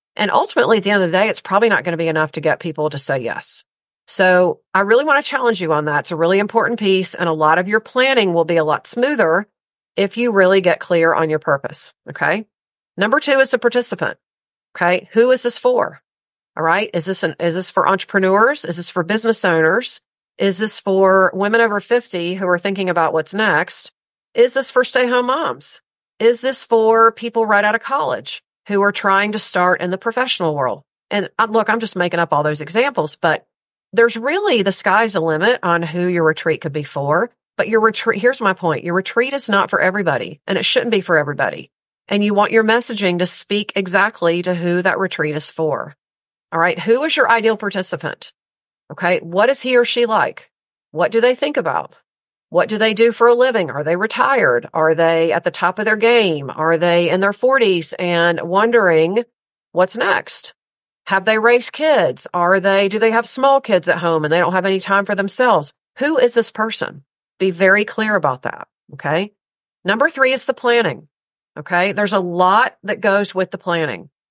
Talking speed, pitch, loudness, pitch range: 210 wpm, 195 Hz, -16 LUFS, 170-230 Hz